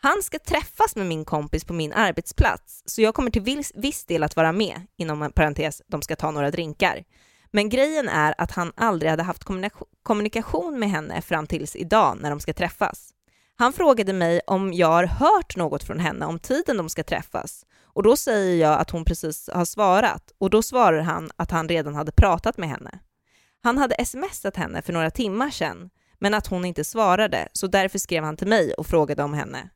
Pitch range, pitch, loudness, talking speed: 160-220 Hz, 180 Hz, -23 LUFS, 205 wpm